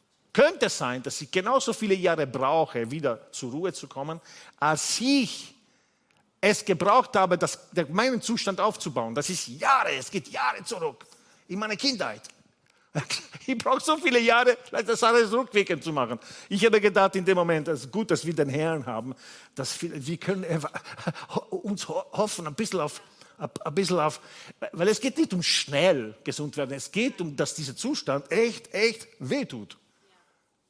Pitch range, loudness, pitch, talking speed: 150-225 Hz, -26 LUFS, 185 Hz, 170 wpm